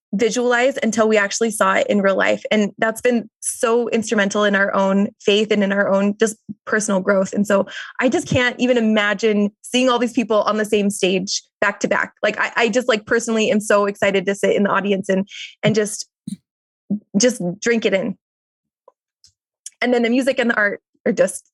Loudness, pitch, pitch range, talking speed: -18 LUFS, 215 Hz, 200-235 Hz, 205 wpm